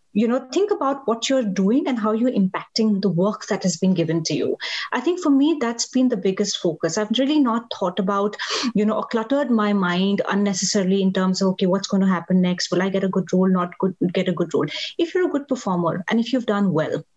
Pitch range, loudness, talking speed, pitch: 190-240 Hz, -21 LUFS, 250 wpm, 205 Hz